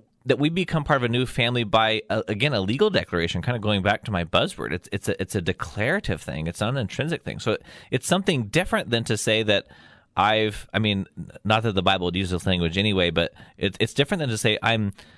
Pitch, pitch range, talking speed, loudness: 110 Hz, 95-120 Hz, 245 wpm, -24 LUFS